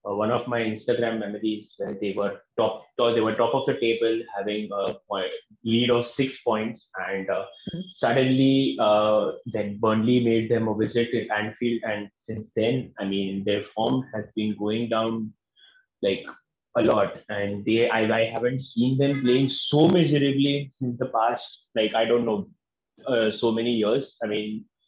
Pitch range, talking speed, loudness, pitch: 105-125 Hz, 170 wpm, -25 LUFS, 115 Hz